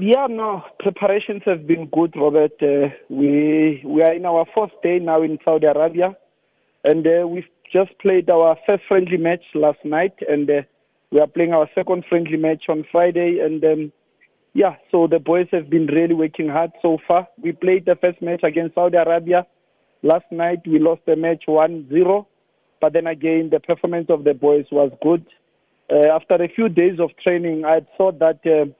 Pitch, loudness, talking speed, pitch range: 165 Hz, -18 LUFS, 190 wpm, 155-180 Hz